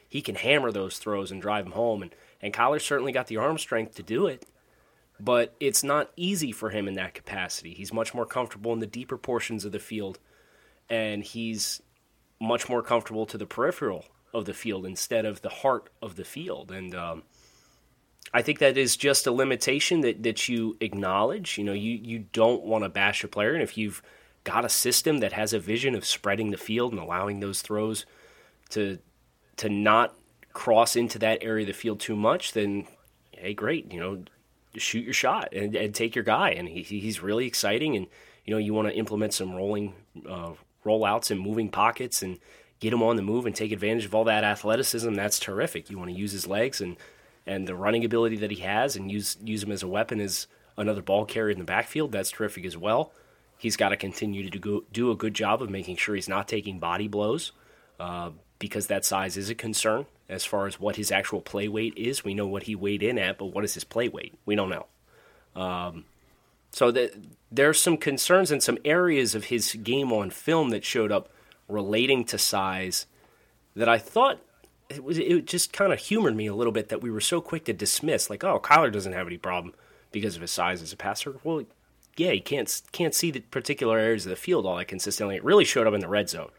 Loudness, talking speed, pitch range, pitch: -27 LUFS, 220 wpm, 100-115 Hz, 105 Hz